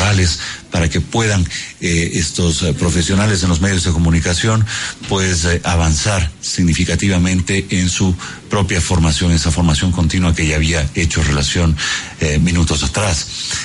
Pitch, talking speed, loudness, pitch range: 90 Hz, 135 wpm, -15 LUFS, 85-95 Hz